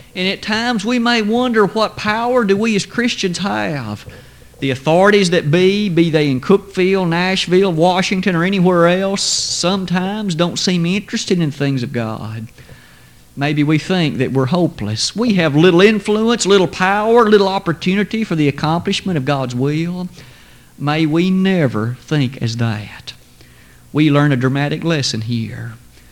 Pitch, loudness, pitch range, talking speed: 170 Hz, -15 LUFS, 135-195 Hz, 150 wpm